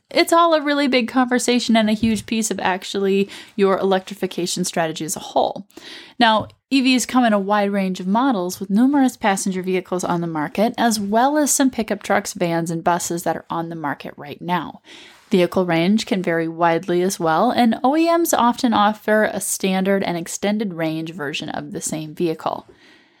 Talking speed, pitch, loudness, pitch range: 185 wpm, 200 Hz, -19 LUFS, 175-245 Hz